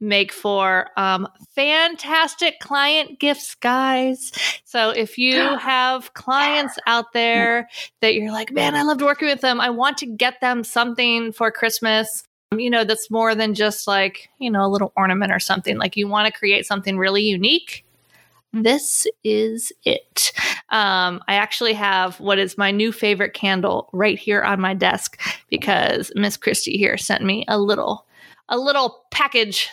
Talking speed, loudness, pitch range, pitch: 170 wpm, -19 LUFS, 205-260 Hz, 225 Hz